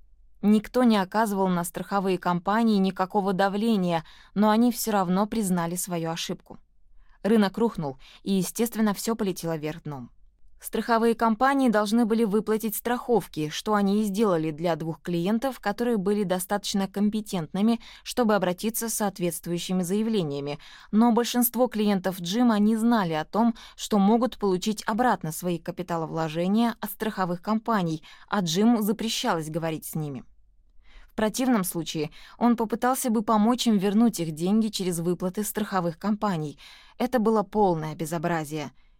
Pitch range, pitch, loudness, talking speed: 175-225 Hz, 205 Hz, -25 LUFS, 135 wpm